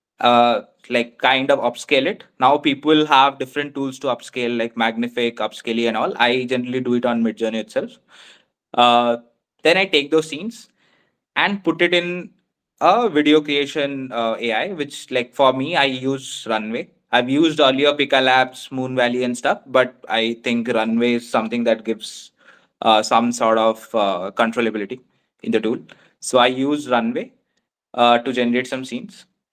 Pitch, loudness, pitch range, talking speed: 125 Hz, -19 LUFS, 115-140 Hz, 170 wpm